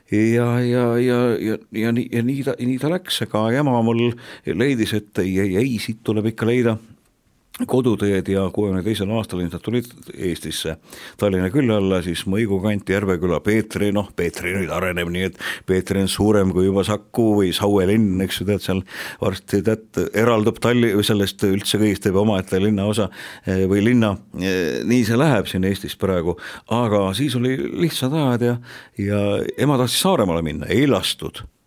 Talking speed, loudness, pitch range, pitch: 175 wpm, -20 LUFS, 95-120 Hz, 105 Hz